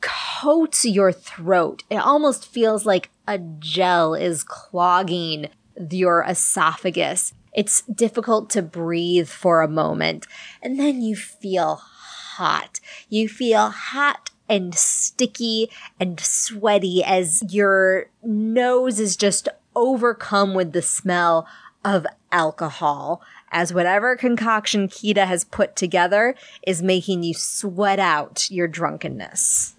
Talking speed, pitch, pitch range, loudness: 115 wpm, 195 Hz, 175-225 Hz, -20 LUFS